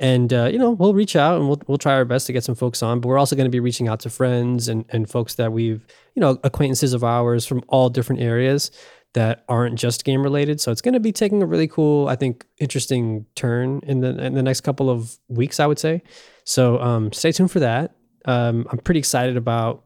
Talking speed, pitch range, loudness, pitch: 250 wpm, 120-145 Hz, -20 LUFS, 130 Hz